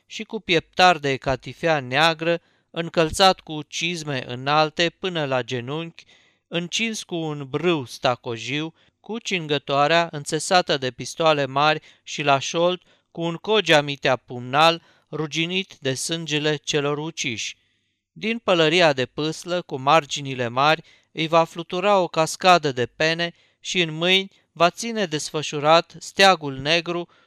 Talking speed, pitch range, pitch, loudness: 130 wpm, 140-175 Hz, 160 Hz, -21 LUFS